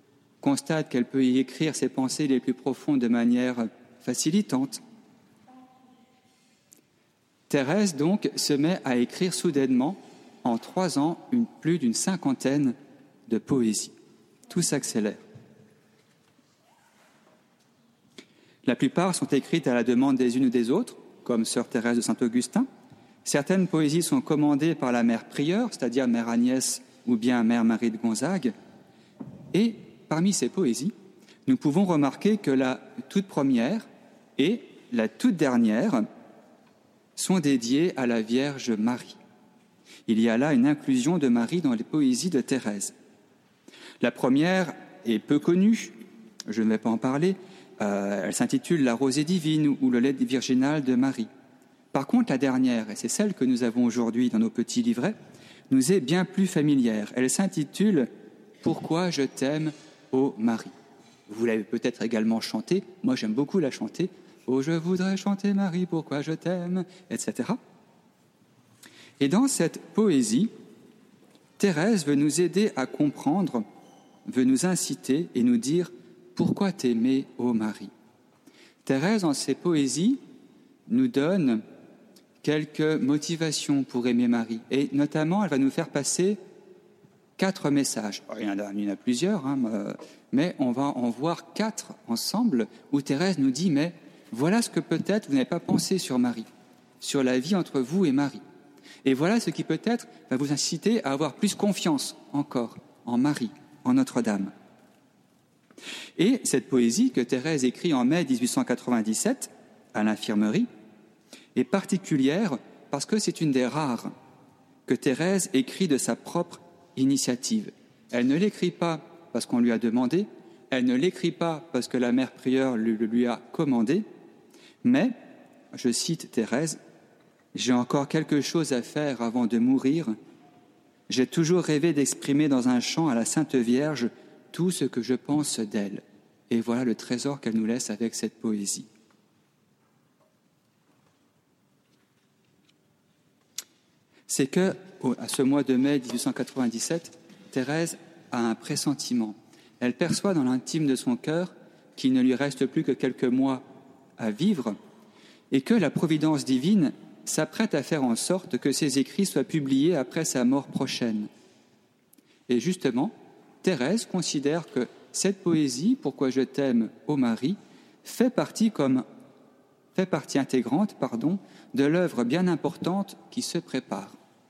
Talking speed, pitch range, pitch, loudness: 145 wpm, 125-200 Hz, 150 Hz, -26 LUFS